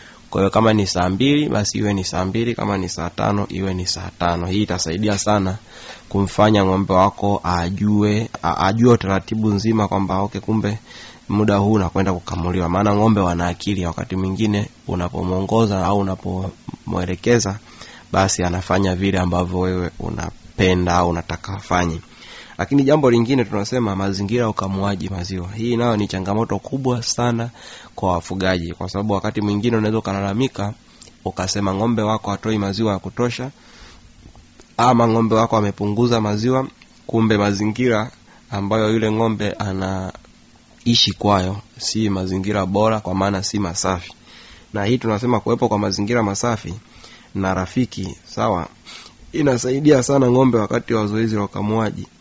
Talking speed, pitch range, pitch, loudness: 135 wpm, 95-110 Hz, 100 Hz, -19 LUFS